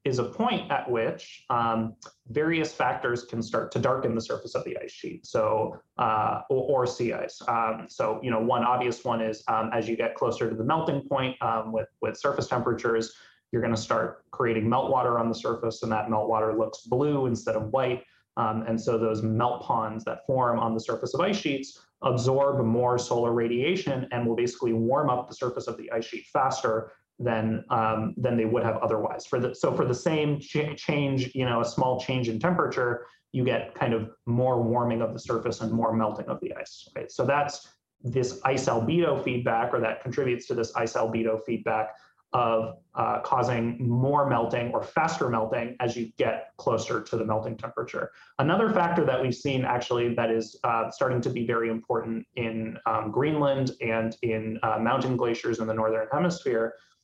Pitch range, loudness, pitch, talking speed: 115-130 Hz, -27 LUFS, 120 Hz, 195 wpm